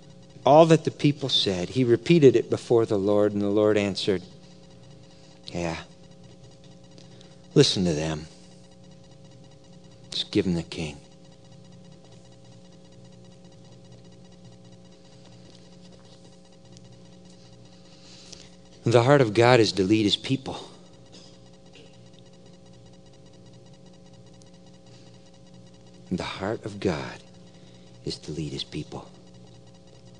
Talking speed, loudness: 85 wpm, -23 LUFS